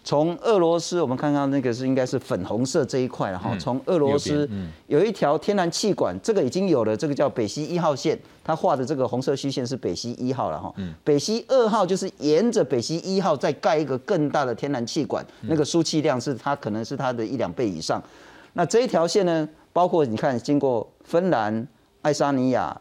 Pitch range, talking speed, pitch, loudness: 130-170 Hz, 320 characters per minute, 145 Hz, -23 LUFS